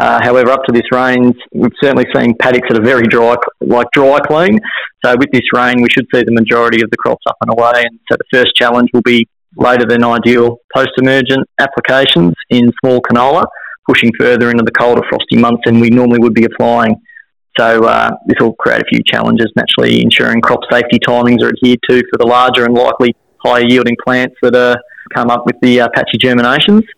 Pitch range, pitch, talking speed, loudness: 120-125 Hz, 120 Hz, 205 wpm, -9 LUFS